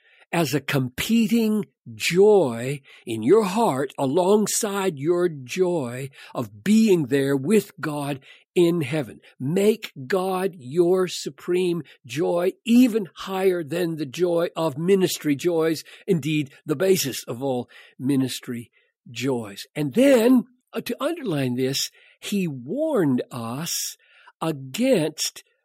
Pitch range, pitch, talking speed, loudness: 140-205 Hz, 170 Hz, 110 wpm, -23 LUFS